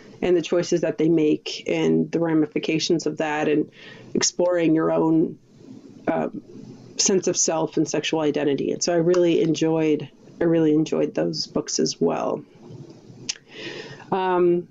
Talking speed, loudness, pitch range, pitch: 145 wpm, -22 LUFS, 150-175 Hz, 160 Hz